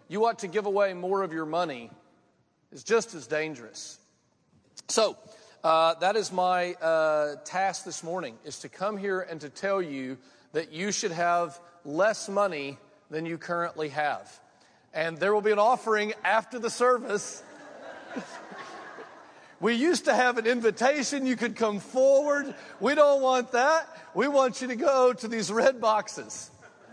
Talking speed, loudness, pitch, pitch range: 160 wpm, -27 LUFS, 200 Hz, 165-240 Hz